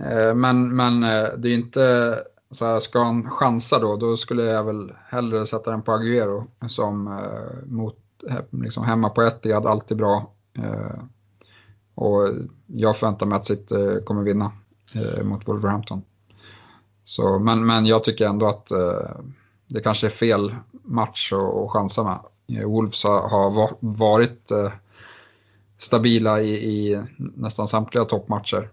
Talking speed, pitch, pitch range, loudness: 125 wpm, 110 Hz, 105-115 Hz, -22 LUFS